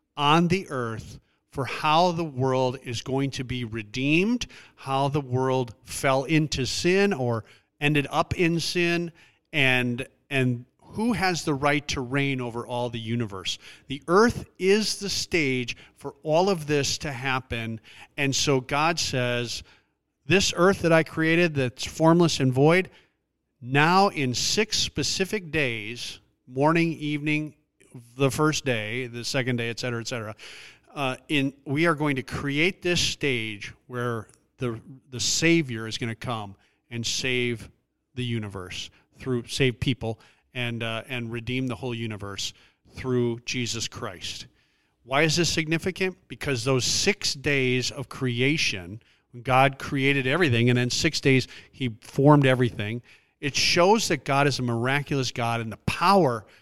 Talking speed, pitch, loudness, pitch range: 150 wpm, 130 Hz, -25 LUFS, 120-150 Hz